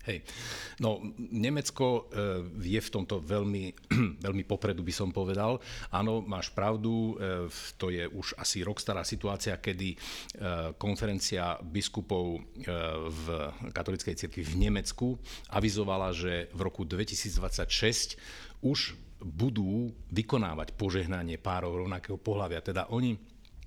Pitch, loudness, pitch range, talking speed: 100 Hz, -33 LUFS, 90-110 Hz, 110 wpm